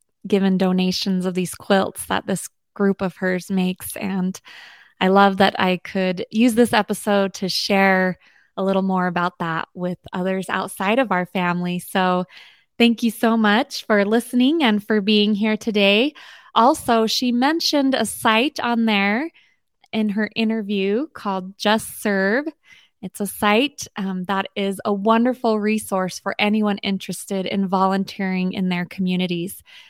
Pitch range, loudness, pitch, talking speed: 190-225 Hz, -20 LUFS, 200 Hz, 150 wpm